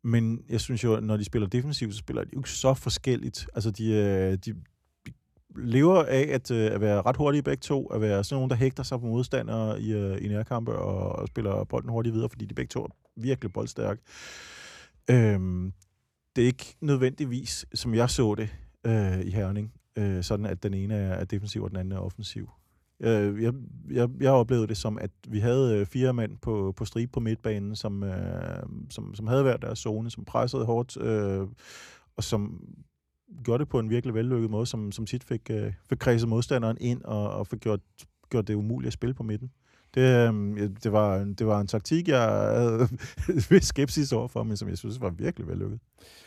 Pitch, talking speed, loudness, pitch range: 115 Hz, 195 wpm, -28 LUFS, 105-125 Hz